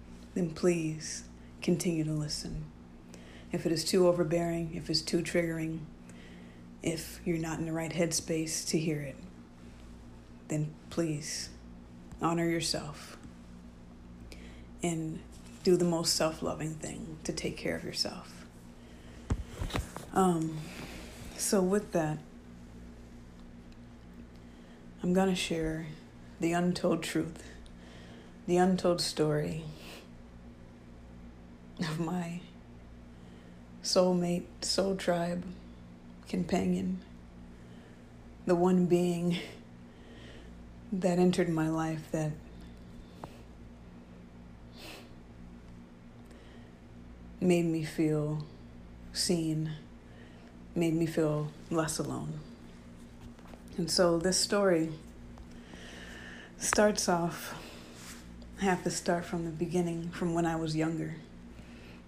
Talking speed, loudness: 90 wpm, -32 LUFS